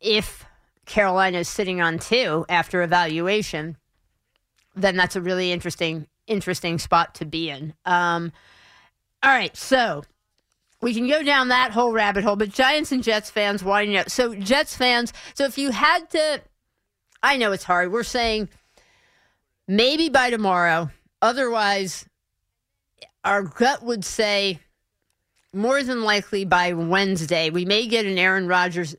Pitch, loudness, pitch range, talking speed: 200 Hz, -21 LUFS, 175-235 Hz, 145 wpm